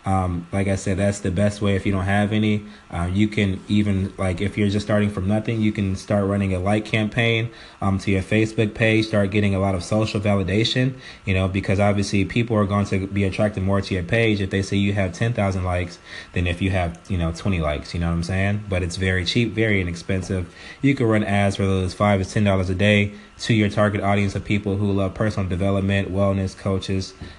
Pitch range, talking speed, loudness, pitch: 95-105 Hz, 235 wpm, -22 LUFS, 100 Hz